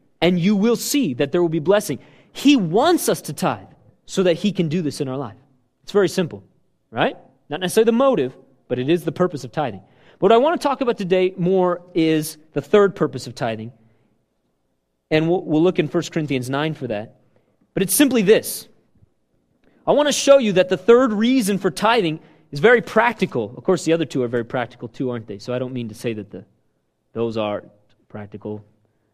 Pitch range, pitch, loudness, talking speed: 125-190 Hz, 155 Hz, -19 LUFS, 210 wpm